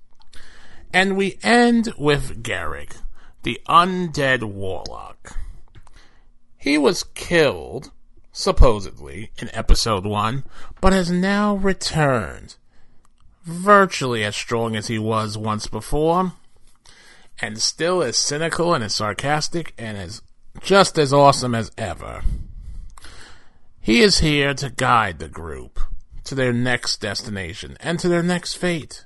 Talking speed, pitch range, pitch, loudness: 120 wpm, 110-170 Hz, 130 Hz, -20 LUFS